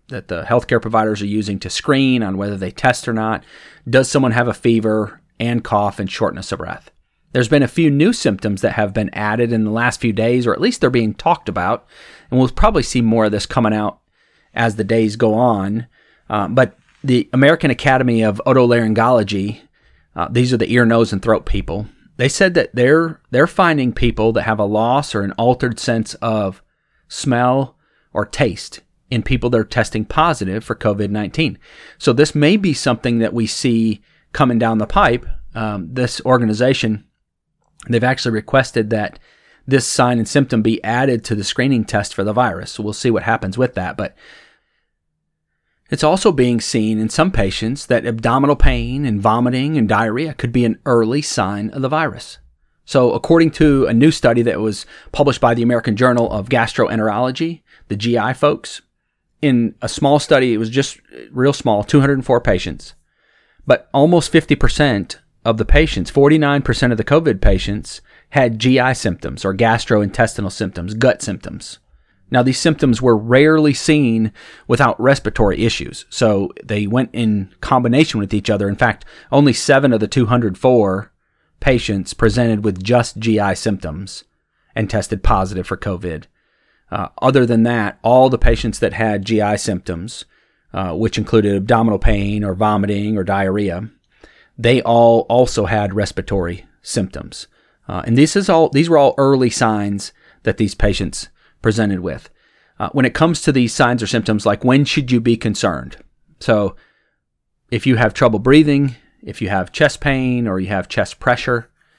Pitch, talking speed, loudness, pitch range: 115 Hz, 175 wpm, -16 LUFS, 105-130 Hz